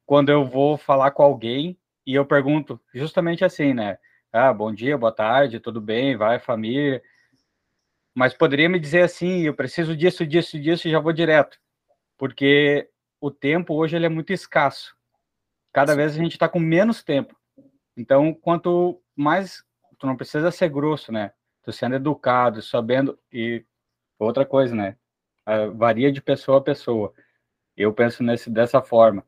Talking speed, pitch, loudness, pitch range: 160 wpm, 140 Hz, -21 LUFS, 120-165 Hz